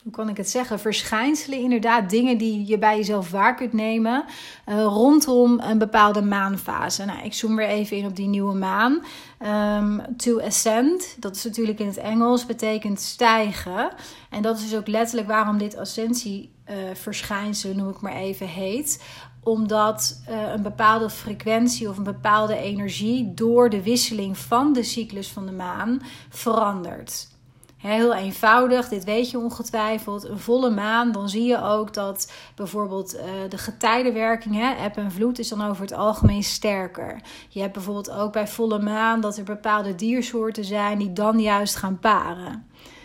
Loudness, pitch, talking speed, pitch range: -22 LUFS, 215 Hz, 165 wpm, 205-230 Hz